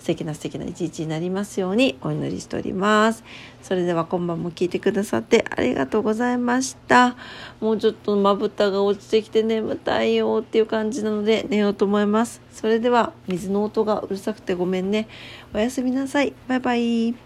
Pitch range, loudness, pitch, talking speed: 185-225 Hz, -22 LUFS, 210 Hz, 405 characters per minute